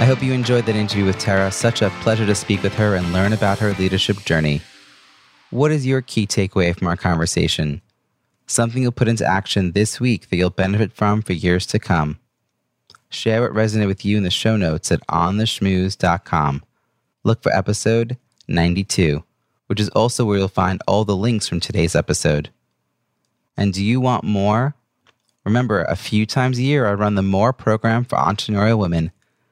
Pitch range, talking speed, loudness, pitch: 95-115 Hz, 185 wpm, -19 LUFS, 105 Hz